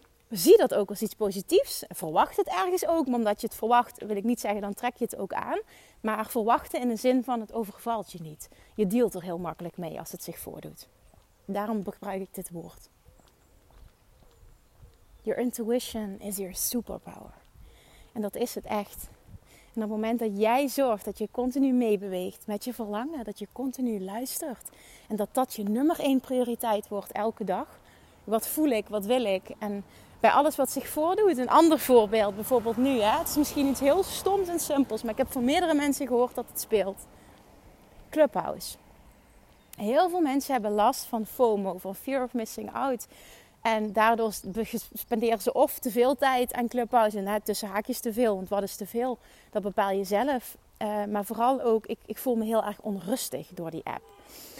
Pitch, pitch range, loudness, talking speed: 225 Hz, 205-255 Hz, -28 LUFS, 195 wpm